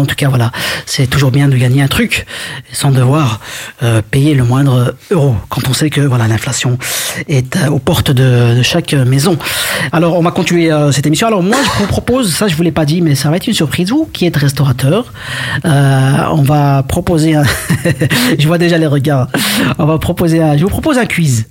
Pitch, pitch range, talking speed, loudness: 145 Hz, 130-165 Hz, 220 wpm, -11 LUFS